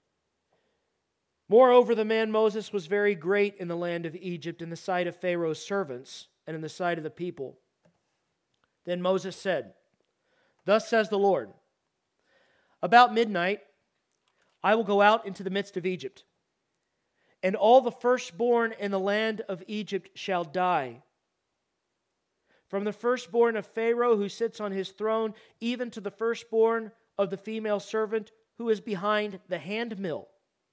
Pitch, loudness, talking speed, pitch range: 205 Hz, -27 LUFS, 150 wpm, 185-225 Hz